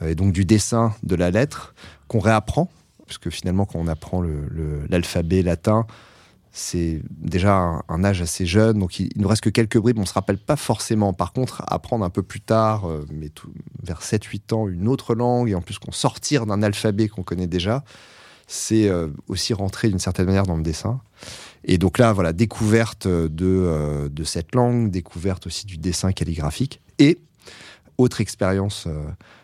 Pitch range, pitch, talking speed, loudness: 90-115 Hz, 100 Hz, 185 wpm, -22 LUFS